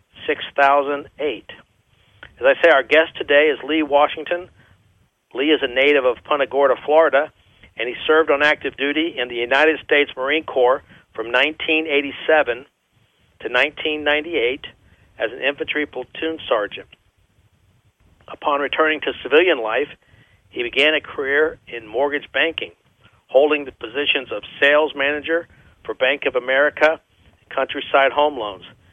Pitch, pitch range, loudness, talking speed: 145 Hz, 135-155 Hz, -18 LUFS, 135 wpm